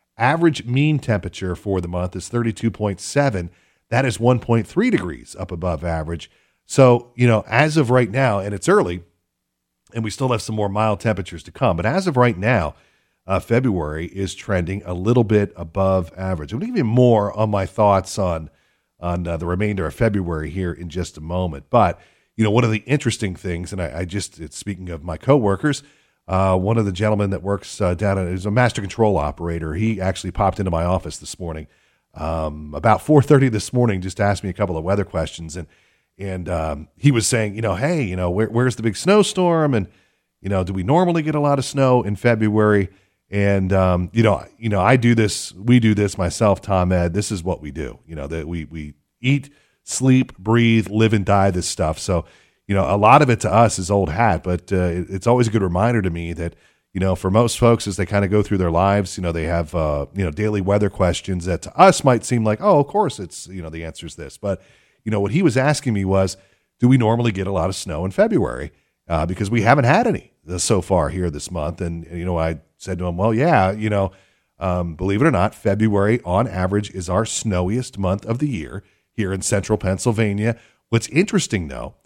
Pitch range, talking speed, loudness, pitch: 90-115 Hz, 225 wpm, -19 LUFS, 100 Hz